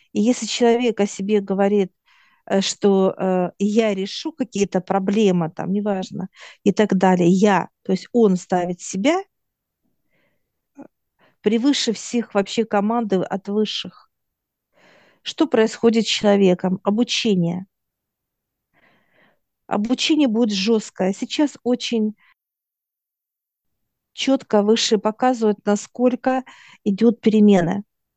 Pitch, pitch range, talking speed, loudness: 210 Hz, 195-235 Hz, 95 wpm, -20 LUFS